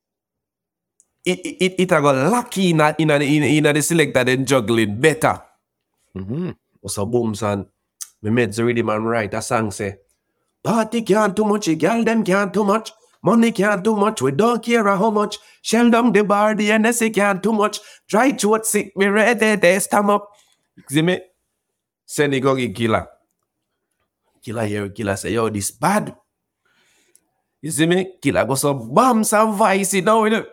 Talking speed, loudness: 180 wpm, -18 LUFS